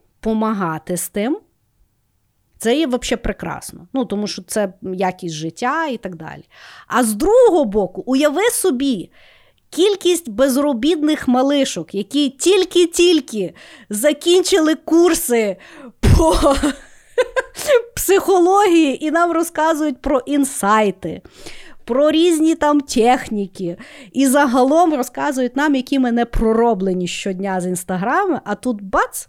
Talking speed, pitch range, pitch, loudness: 110 wpm, 210-320 Hz, 270 Hz, -17 LUFS